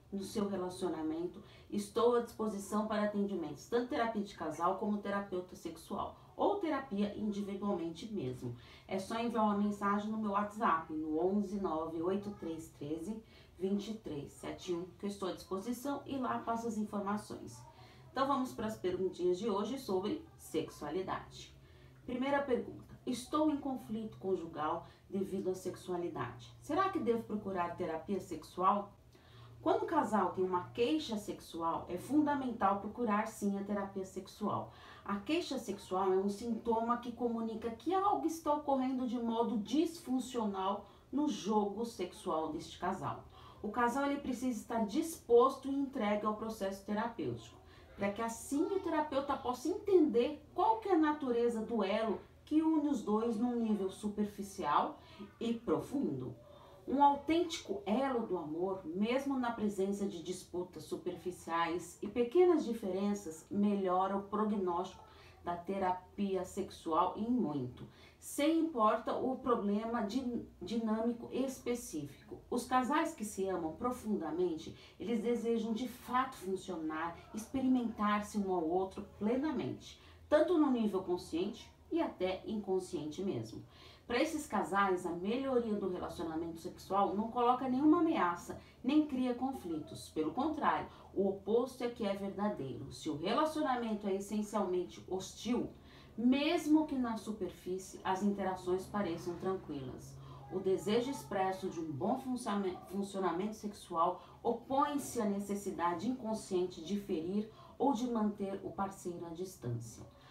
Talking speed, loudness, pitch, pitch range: 130 wpm, -36 LUFS, 210 Hz, 185-245 Hz